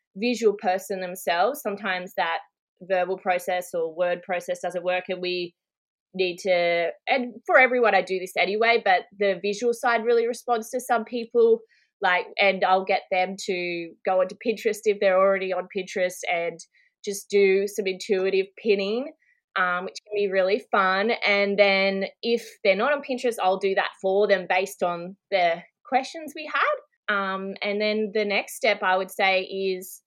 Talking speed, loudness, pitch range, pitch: 170 wpm, -24 LUFS, 185-220 Hz, 195 Hz